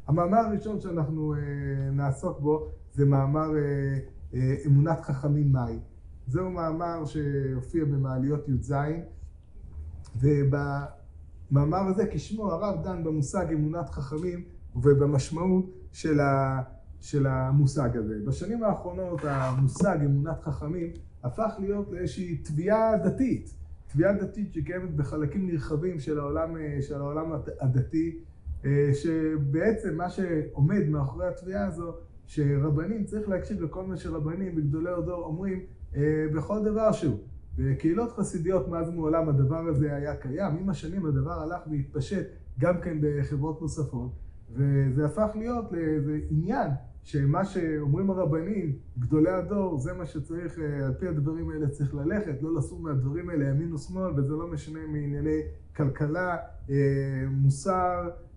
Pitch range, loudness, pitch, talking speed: 140-175 Hz, -28 LUFS, 155 Hz, 115 wpm